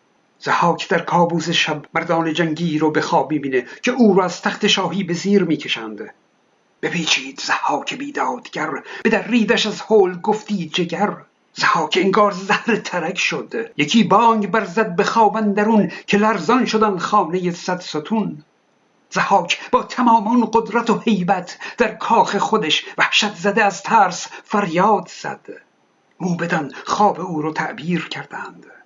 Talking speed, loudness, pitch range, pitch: 135 wpm, -18 LUFS, 170-215 Hz, 200 Hz